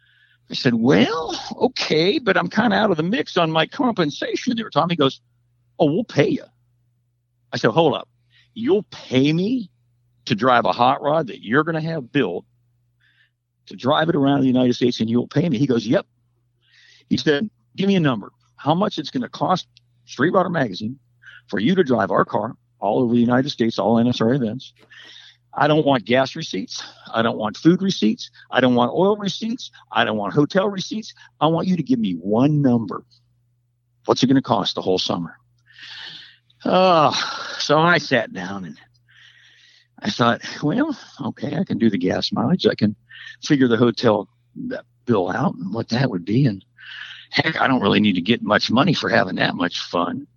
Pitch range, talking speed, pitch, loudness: 120-160 Hz, 195 wpm, 125 Hz, -20 LUFS